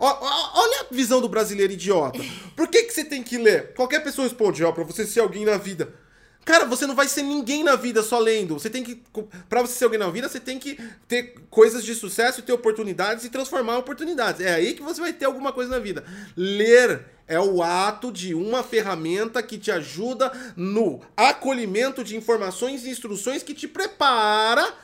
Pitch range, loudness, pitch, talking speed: 210-265 Hz, -22 LUFS, 240 Hz, 205 wpm